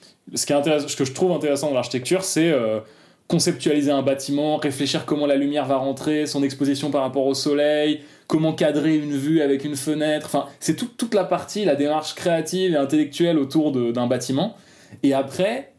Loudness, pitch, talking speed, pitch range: -22 LUFS, 150 Hz, 195 wpm, 140-160 Hz